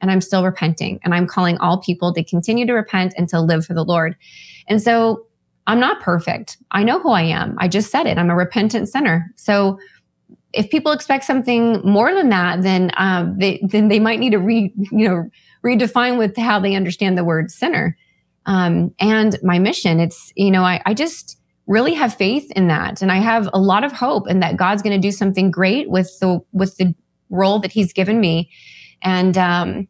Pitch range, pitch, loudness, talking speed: 180-215 Hz, 190 Hz, -17 LUFS, 210 wpm